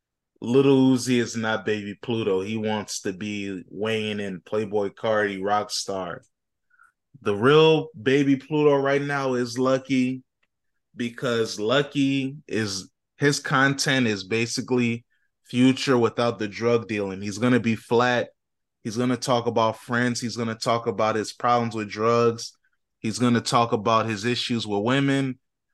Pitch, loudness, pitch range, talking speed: 120 Hz, -23 LUFS, 110-130 Hz, 140 wpm